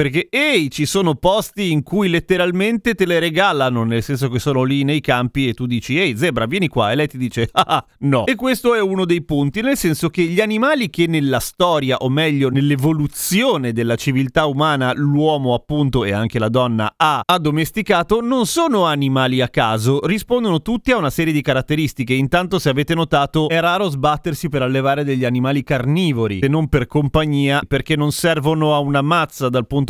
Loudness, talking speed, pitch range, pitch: -17 LUFS, 190 wpm, 135-175 Hz, 150 Hz